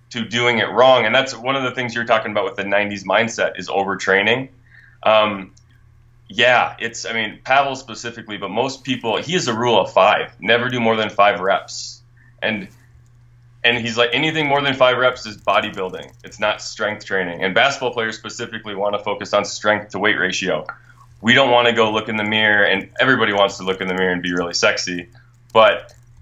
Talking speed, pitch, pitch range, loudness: 205 wpm, 115 Hz, 105-120 Hz, -18 LUFS